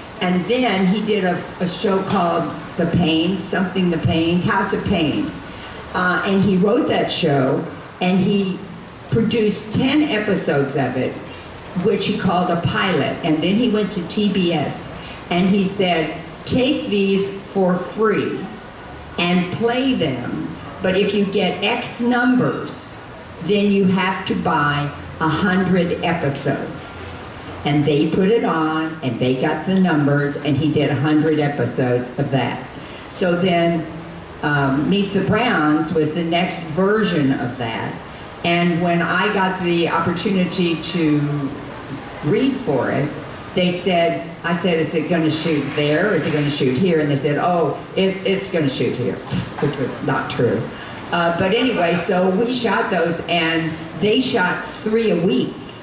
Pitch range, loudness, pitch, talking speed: 155-195 Hz, -19 LUFS, 175 Hz, 160 wpm